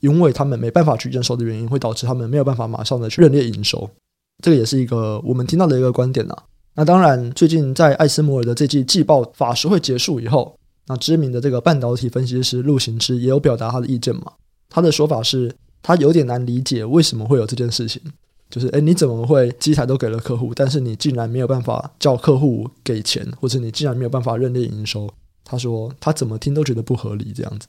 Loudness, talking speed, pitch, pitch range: -17 LUFS, 365 characters per minute, 125 Hz, 120-145 Hz